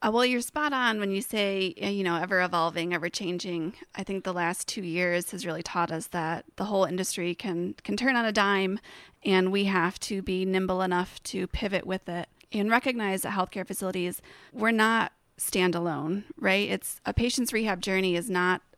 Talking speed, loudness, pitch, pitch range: 190 wpm, -28 LUFS, 190 Hz, 175-205 Hz